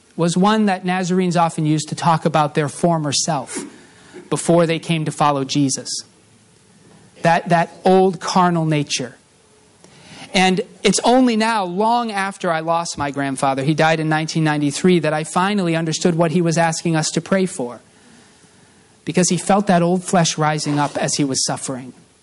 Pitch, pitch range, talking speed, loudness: 165 Hz, 150-185 Hz, 165 wpm, -18 LUFS